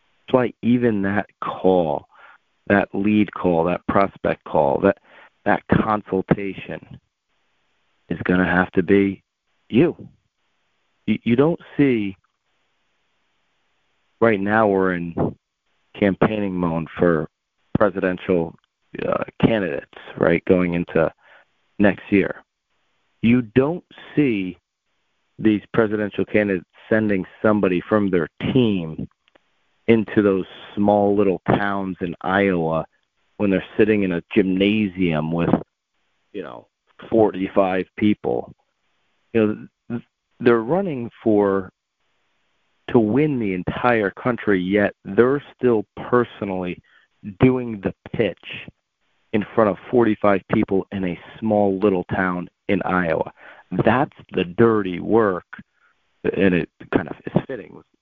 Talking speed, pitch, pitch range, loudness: 115 wpm, 100 Hz, 90-110 Hz, -21 LUFS